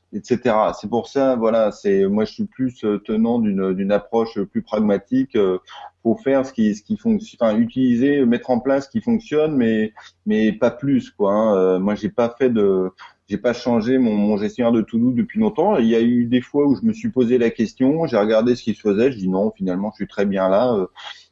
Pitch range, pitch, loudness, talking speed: 105-155 Hz, 120 Hz, -19 LUFS, 230 wpm